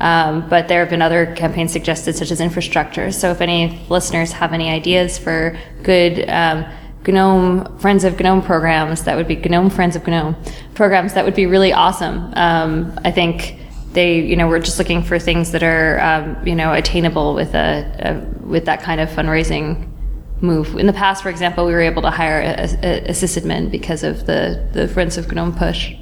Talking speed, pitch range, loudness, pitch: 200 wpm, 165-180 Hz, -16 LUFS, 170 Hz